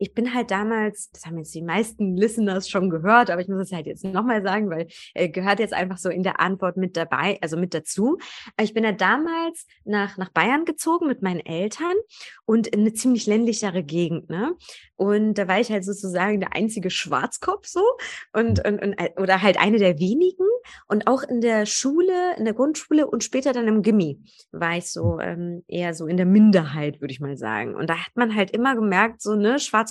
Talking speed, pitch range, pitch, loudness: 215 wpm, 185-235 Hz, 205 Hz, -22 LUFS